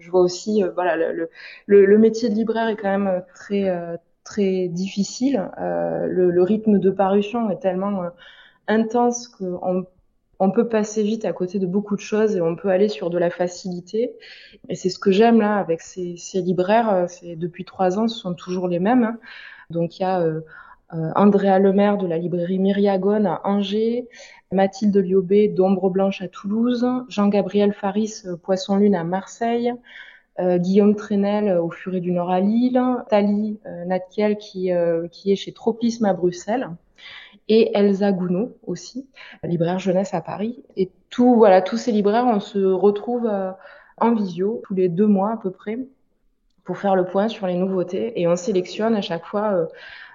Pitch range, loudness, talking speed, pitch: 180-220 Hz, -21 LUFS, 185 wpm, 195 Hz